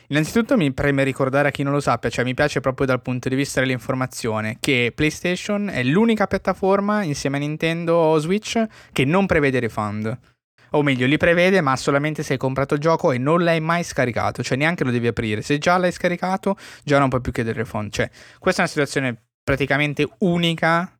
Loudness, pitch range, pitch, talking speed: -20 LUFS, 130-170 Hz, 145 Hz, 200 wpm